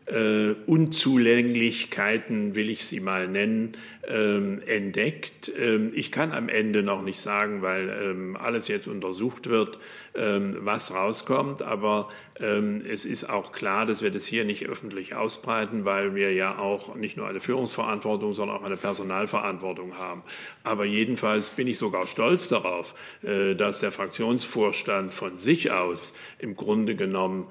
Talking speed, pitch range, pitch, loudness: 150 wpm, 100-110 Hz, 105 Hz, -27 LUFS